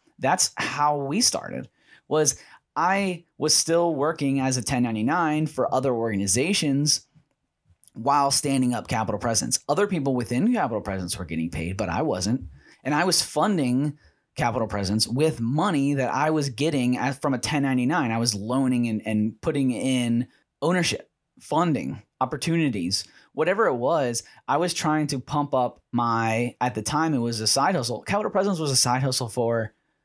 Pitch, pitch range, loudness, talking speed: 130 Hz, 115-150 Hz, -24 LUFS, 160 wpm